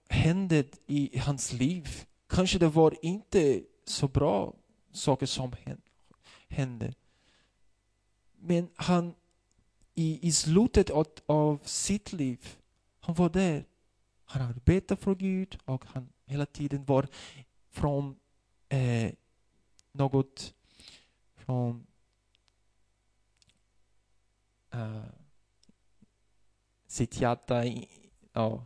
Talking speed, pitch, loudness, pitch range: 90 wpm, 130 Hz, -30 LUFS, 110-155 Hz